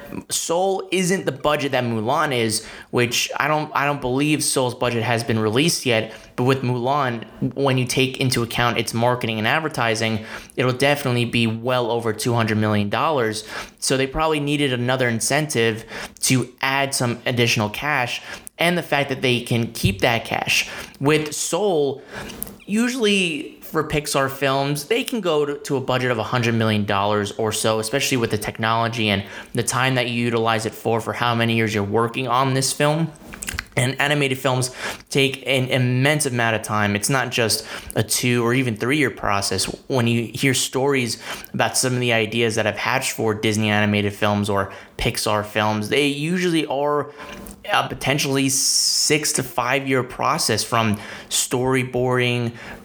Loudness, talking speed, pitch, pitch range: -20 LUFS, 170 wpm, 125 Hz, 115-140 Hz